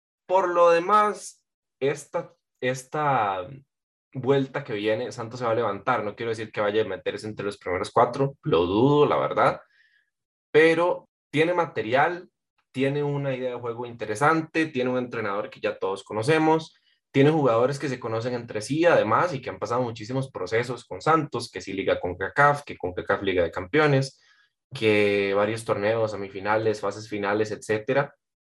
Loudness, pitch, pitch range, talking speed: -25 LUFS, 135 Hz, 110-155 Hz, 165 wpm